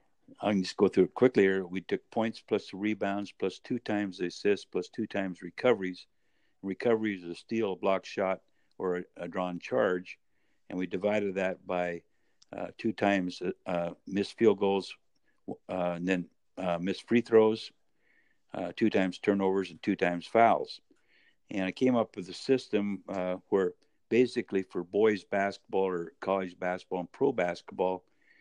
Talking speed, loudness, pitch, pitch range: 170 wpm, -31 LUFS, 95 Hz, 90-105 Hz